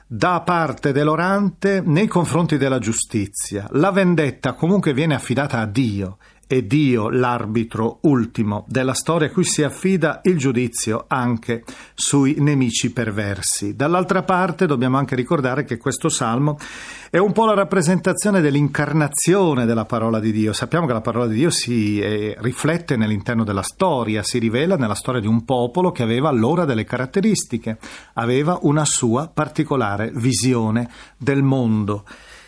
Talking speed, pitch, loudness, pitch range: 145 wpm, 130 Hz, -19 LUFS, 115-160 Hz